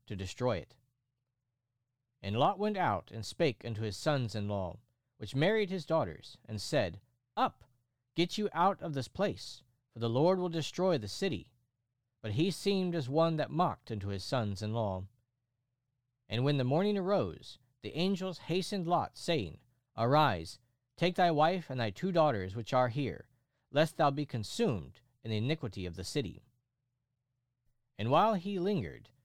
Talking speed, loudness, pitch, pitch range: 165 wpm, -33 LUFS, 125 Hz, 115-160 Hz